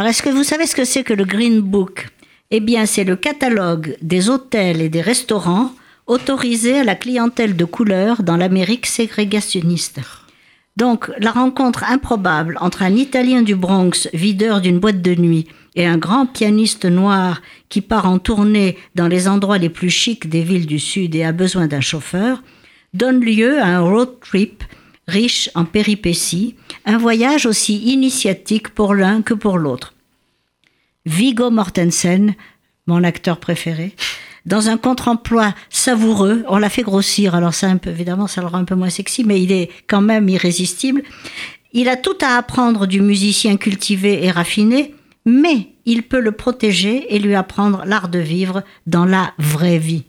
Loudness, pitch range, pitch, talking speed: -15 LUFS, 180-235 Hz, 205 Hz, 170 wpm